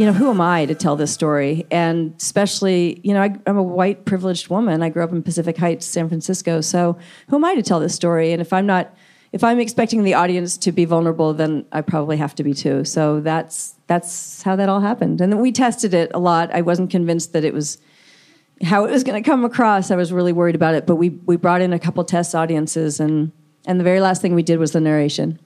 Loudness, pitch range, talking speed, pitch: -18 LUFS, 160-190 Hz, 250 wpm, 175 Hz